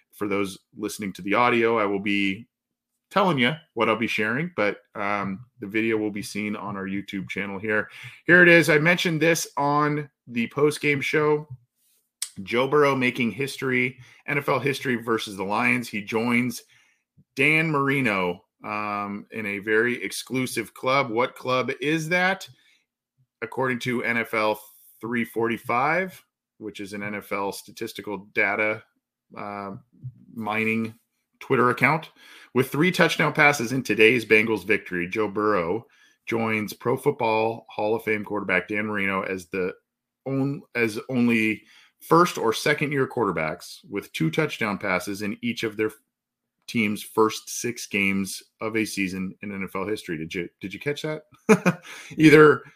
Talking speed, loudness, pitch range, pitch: 145 wpm, -23 LUFS, 105-135 Hz, 115 Hz